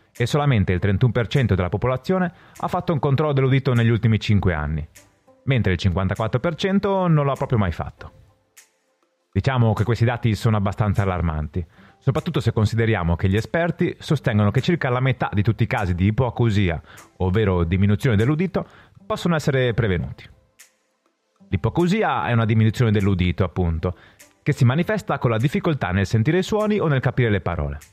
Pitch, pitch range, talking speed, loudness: 115 Hz, 100-145 Hz, 160 wpm, -21 LUFS